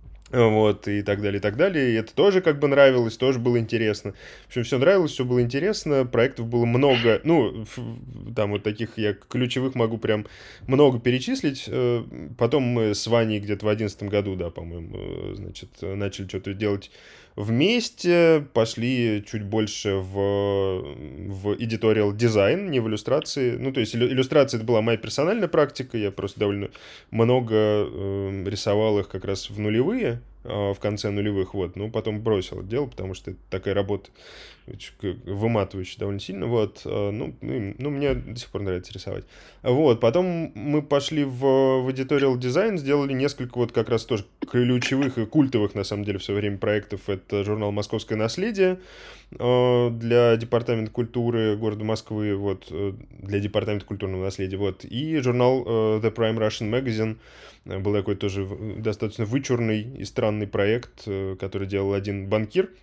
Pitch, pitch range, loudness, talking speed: 110 Hz, 100-125 Hz, -24 LUFS, 160 wpm